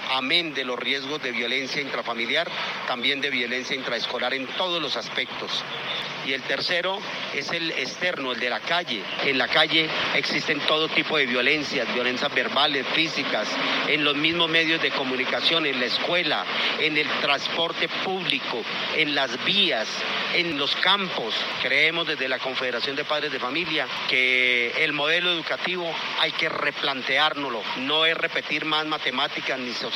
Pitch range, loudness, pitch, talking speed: 130-160 Hz, -23 LUFS, 150 Hz, 155 wpm